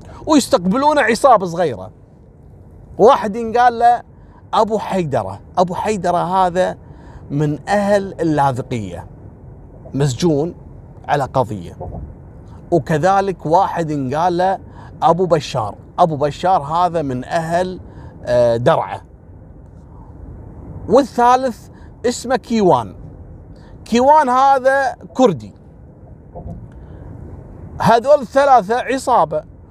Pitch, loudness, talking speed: 170 Hz, -16 LUFS, 75 wpm